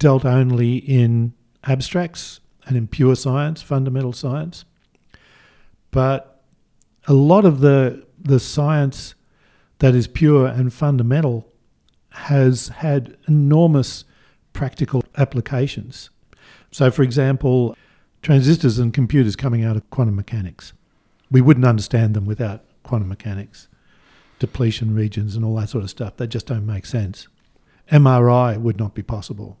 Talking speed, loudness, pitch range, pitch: 130 wpm, -18 LUFS, 115-135 Hz, 125 Hz